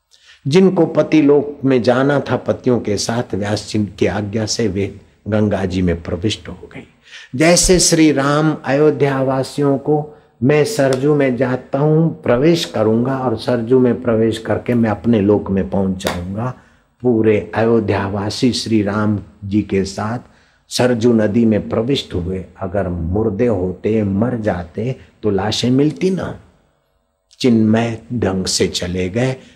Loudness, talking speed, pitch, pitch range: -16 LUFS, 130 wpm, 115 Hz, 100-135 Hz